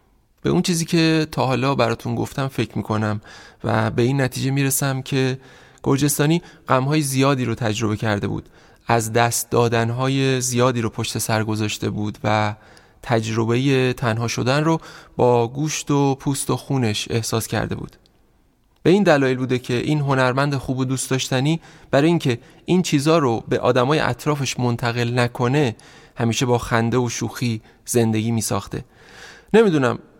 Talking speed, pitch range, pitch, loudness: 150 wpm, 115-140 Hz, 125 Hz, -20 LUFS